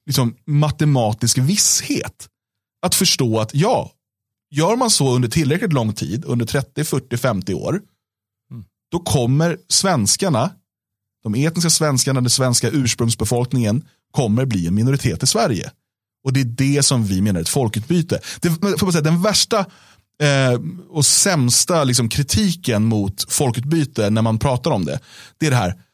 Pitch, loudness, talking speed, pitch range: 135 Hz, -17 LUFS, 150 wpm, 115-155 Hz